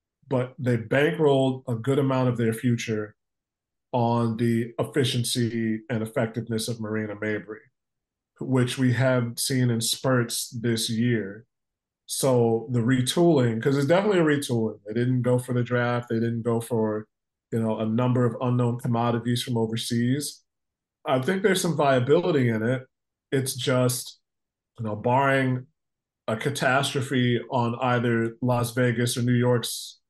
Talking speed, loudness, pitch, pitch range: 145 wpm, -25 LUFS, 120 Hz, 115-130 Hz